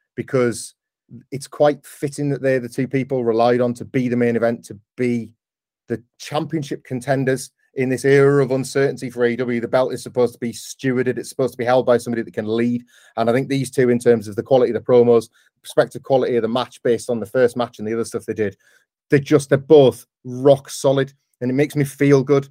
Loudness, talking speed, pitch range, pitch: -19 LUFS, 230 wpm, 120-135 Hz, 125 Hz